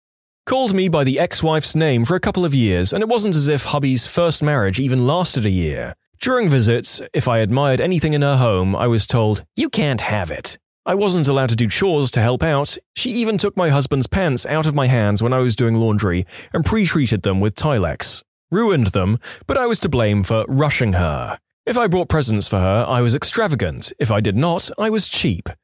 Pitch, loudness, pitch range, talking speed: 130 Hz, -17 LUFS, 110-165 Hz, 220 wpm